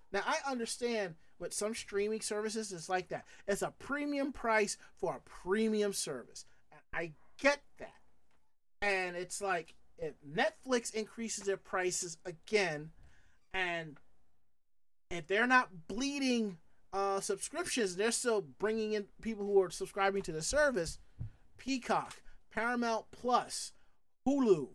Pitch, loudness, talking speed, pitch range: 210 Hz, -35 LUFS, 125 wpm, 190-235 Hz